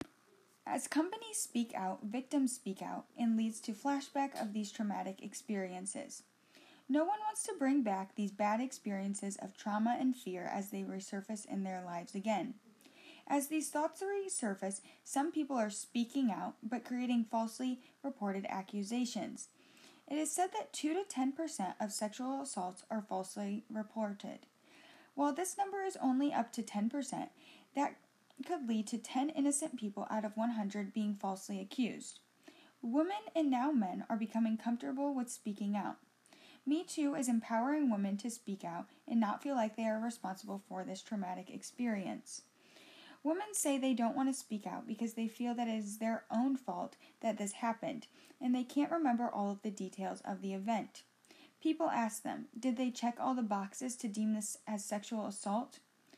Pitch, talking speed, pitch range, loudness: 235 Hz, 170 wpm, 210-280 Hz, -38 LUFS